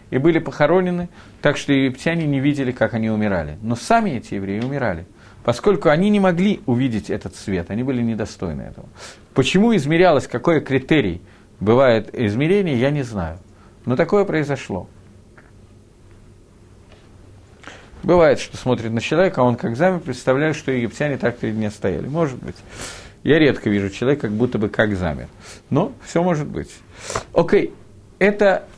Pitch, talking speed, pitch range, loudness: 120 Hz, 150 wpm, 105-150 Hz, -19 LUFS